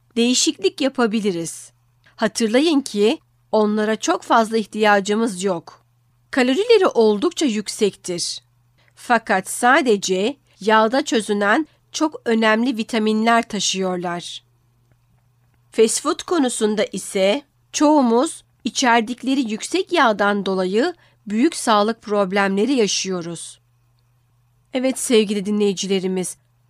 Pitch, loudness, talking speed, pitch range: 210 Hz, -19 LUFS, 80 wpm, 175-235 Hz